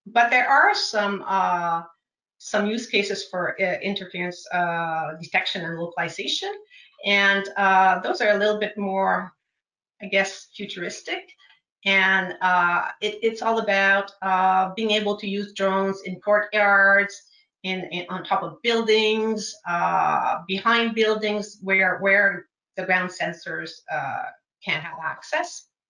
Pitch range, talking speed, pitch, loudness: 185-215 Hz, 135 wpm, 200 Hz, -22 LUFS